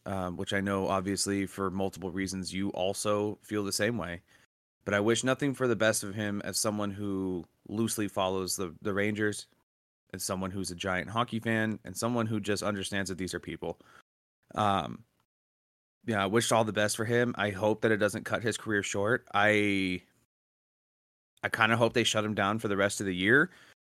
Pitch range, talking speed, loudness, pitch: 95-110 Hz, 200 wpm, -30 LUFS, 100 Hz